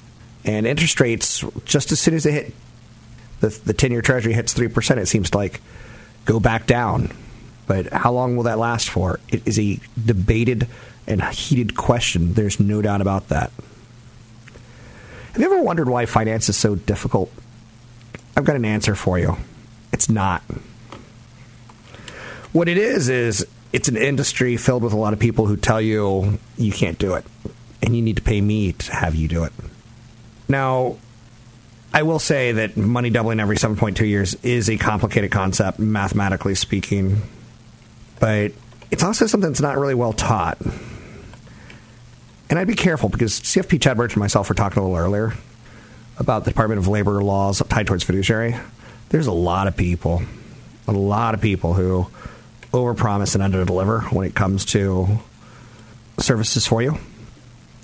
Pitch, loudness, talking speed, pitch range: 115 Hz, -19 LUFS, 165 wpm, 105-120 Hz